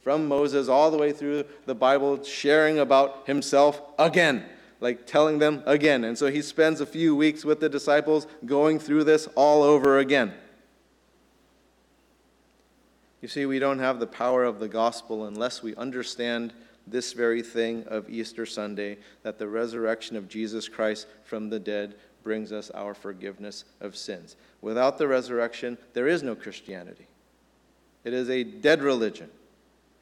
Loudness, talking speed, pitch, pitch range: -25 LUFS, 155 wpm, 125 Hz, 110-145 Hz